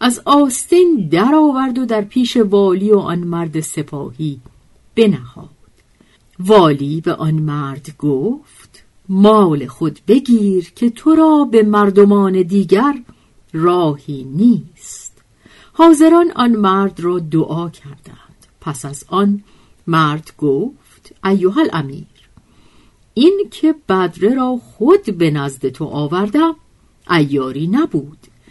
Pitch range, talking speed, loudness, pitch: 155-235 Hz, 110 wpm, -14 LUFS, 190 Hz